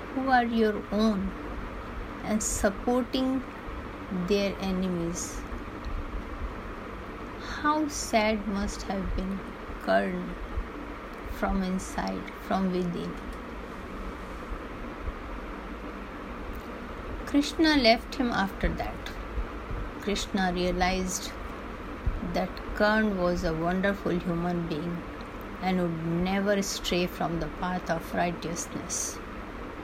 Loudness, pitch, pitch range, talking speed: -30 LUFS, 195 Hz, 180-220 Hz, 80 wpm